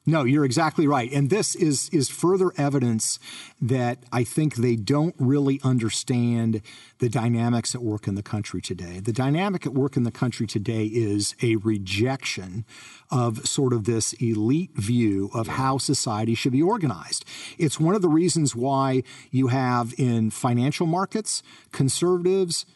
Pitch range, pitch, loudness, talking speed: 115-145 Hz, 130 Hz, -24 LUFS, 160 wpm